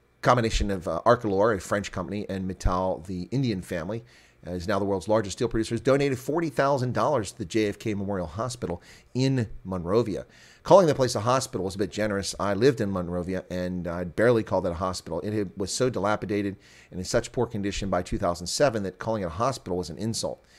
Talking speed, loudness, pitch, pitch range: 215 wpm, -27 LUFS, 100 Hz, 90-115 Hz